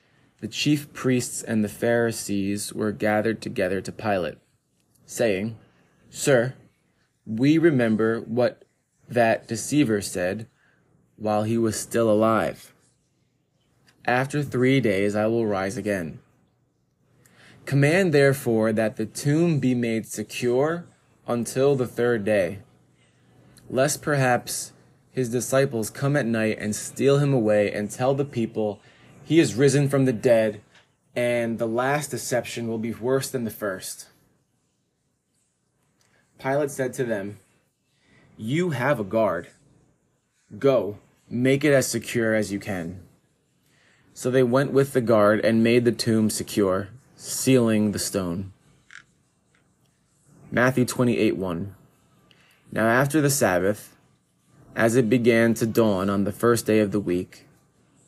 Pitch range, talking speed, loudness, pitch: 105-135 Hz, 125 wpm, -23 LUFS, 115 Hz